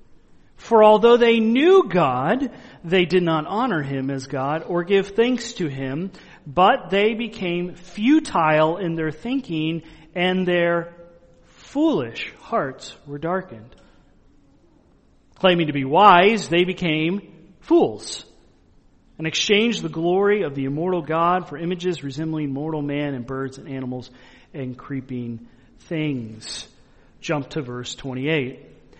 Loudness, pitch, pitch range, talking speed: -21 LUFS, 170 Hz, 145-190 Hz, 125 wpm